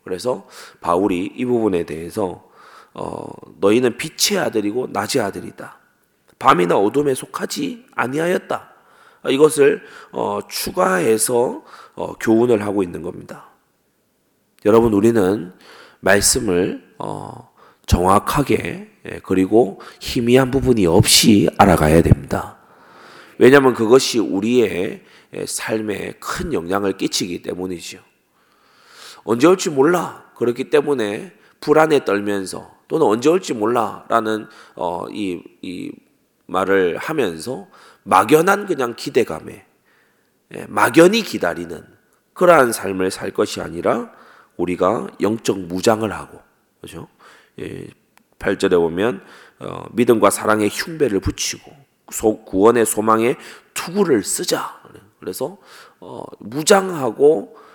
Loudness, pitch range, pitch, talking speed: -17 LUFS, 95-130 Hz, 110 Hz, 235 characters per minute